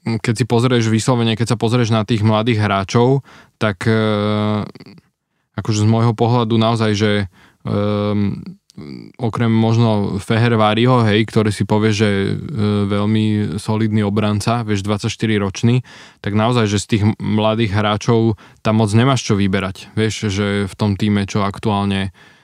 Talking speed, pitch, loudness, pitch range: 145 wpm, 110 Hz, -17 LUFS, 105-115 Hz